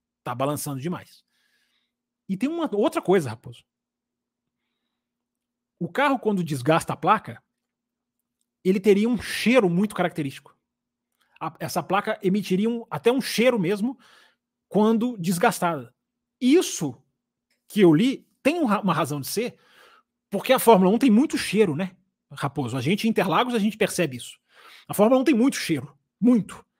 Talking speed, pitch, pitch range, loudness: 145 wpm, 200 Hz, 170-240 Hz, -23 LUFS